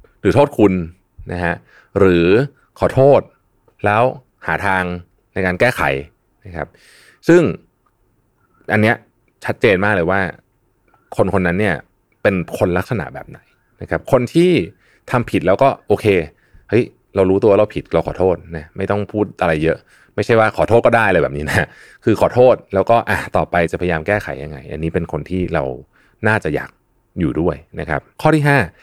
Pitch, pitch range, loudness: 95 Hz, 90-115 Hz, -16 LUFS